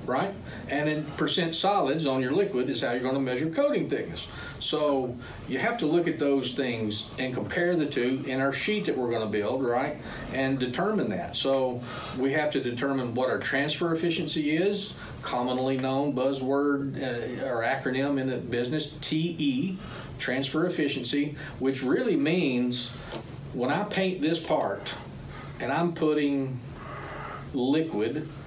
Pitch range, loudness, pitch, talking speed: 130-155 Hz, -28 LUFS, 140 Hz, 155 wpm